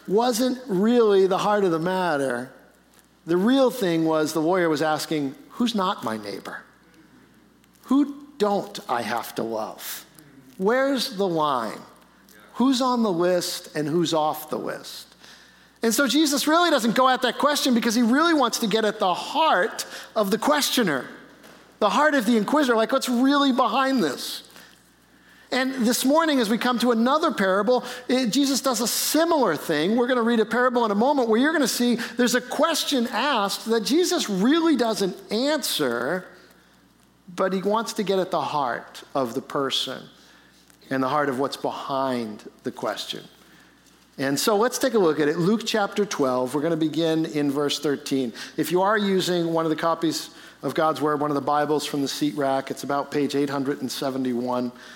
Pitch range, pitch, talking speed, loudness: 155-250 Hz, 205 Hz, 180 wpm, -23 LUFS